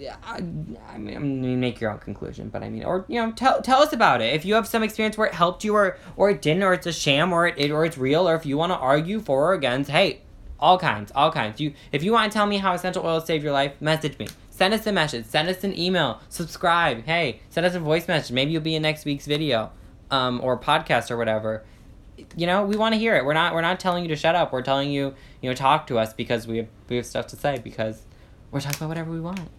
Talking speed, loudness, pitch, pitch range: 280 wpm, -23 LUFS, 155 Hz, 125-180 Hz